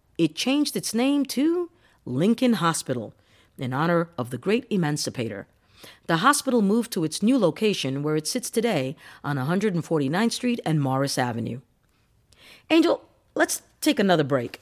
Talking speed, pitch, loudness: 145 wpm, 165 Hz, -24 LUFS